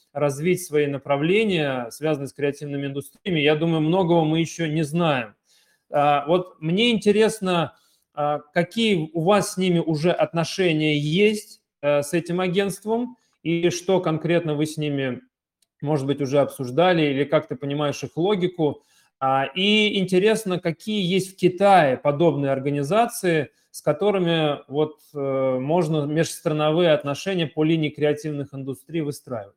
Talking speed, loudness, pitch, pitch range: 130 wpm, -22 LUFS, 160 Hz, 145-180 Hz